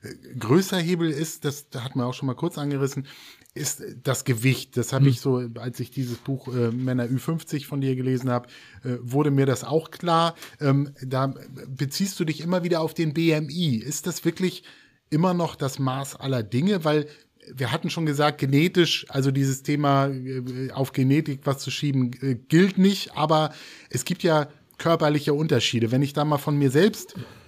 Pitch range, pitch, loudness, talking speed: 130-160 Hz, 140 Hz, -24 LUFS, 185 wpm